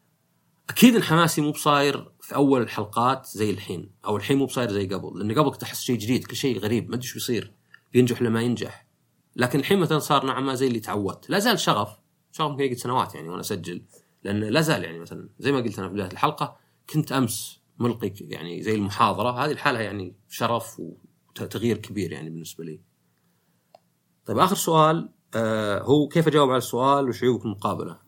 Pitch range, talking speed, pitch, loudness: 105-140 Hz, 185 wpm, 120 Hz, -24 LUFS